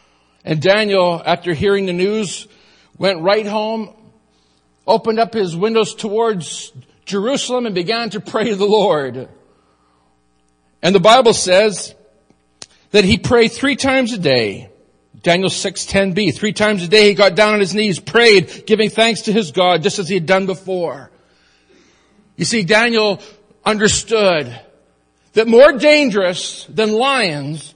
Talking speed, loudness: 145 wpm, -14 LUFS